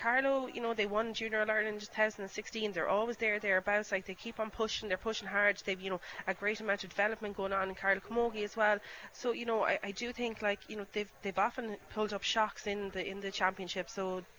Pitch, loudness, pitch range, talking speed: 210 Hz, -35 LUFS, 195-220 Hz, 255 wpm